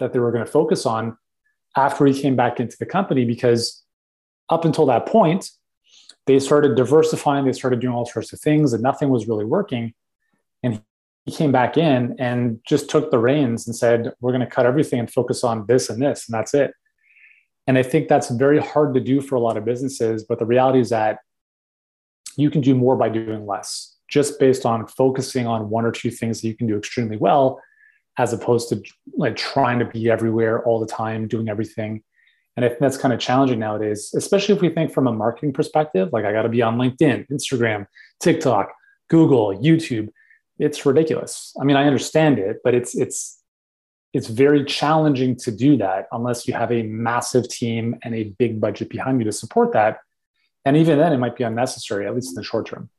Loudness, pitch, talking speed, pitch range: -20 LUFS, 125 Hz, 210 wpm, 115-145 Hz